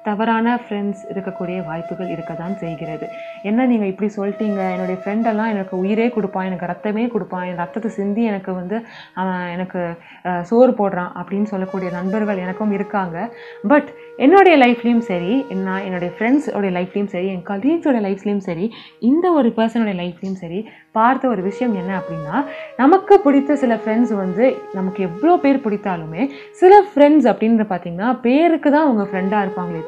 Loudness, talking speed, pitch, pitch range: -18 LUFS, 145 wpm, 210 Hz, 185-240 Hz